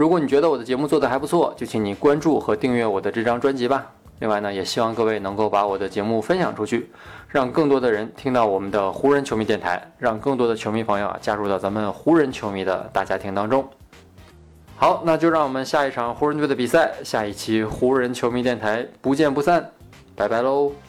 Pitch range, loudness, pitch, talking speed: 100-135 Hz, -21 LUFS, 115 Hz, 340 characters per minute